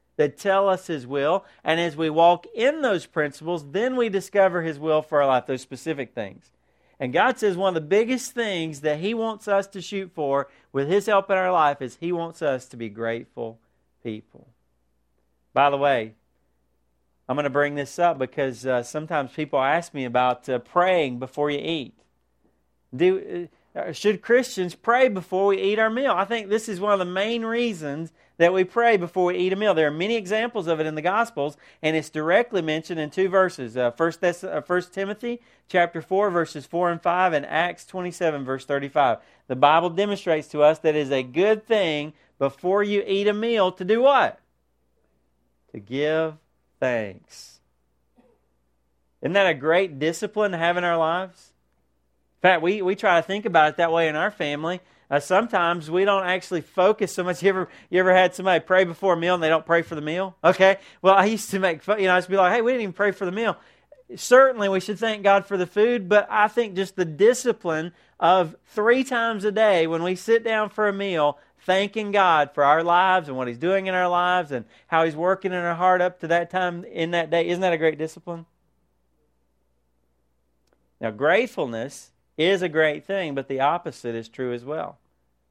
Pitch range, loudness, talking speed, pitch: 145-195 Hz, -22 LUFS, 205 wpm, 170 Hz